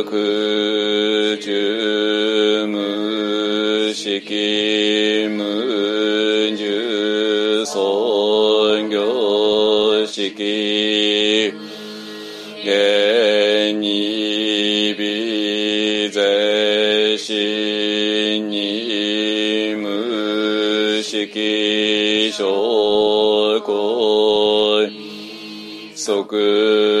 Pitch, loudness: 105 Hz, -17 LUFS